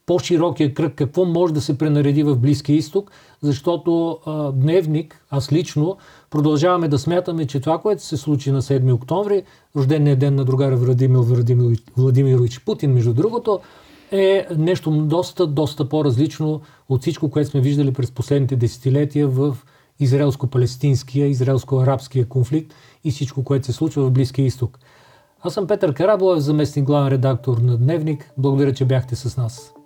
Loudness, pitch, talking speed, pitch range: -19 LUFS, 145 Hz, 145 wpm, 135-160 Hz